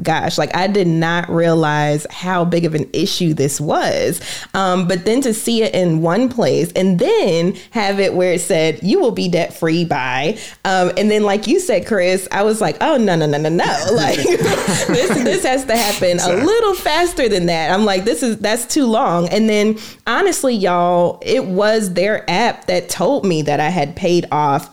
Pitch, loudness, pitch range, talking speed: 185 Hz, -16 LUFS, 170-220 Hz, 210 wpm